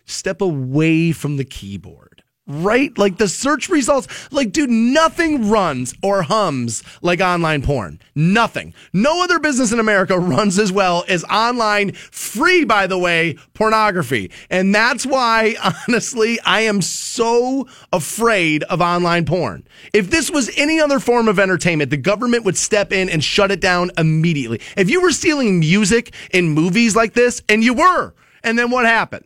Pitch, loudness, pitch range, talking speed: 200 Hz, -16 LUFS, 170-235 Hz, 165 wpm